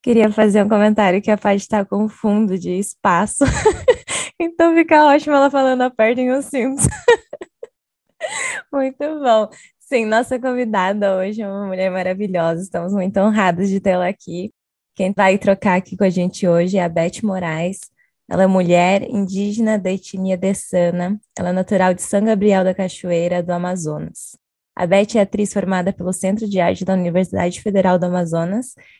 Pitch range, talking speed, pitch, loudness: 185-220 Hz, 170 wpm, 195 Hz, -17 LUFS